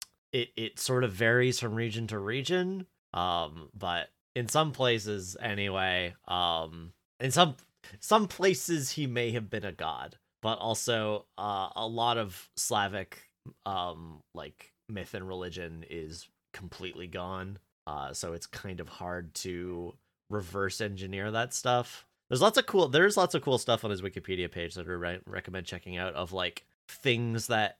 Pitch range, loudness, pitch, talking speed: 90-120 Hz, -31 LUFS, 105 Hz, 160 wpm